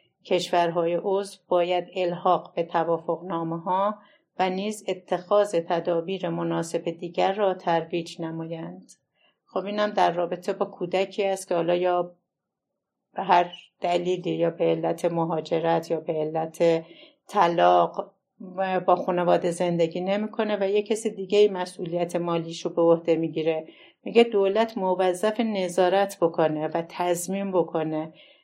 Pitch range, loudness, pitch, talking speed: 170-190 Hz, -25 LUFS, 175 Hz, 130 wpm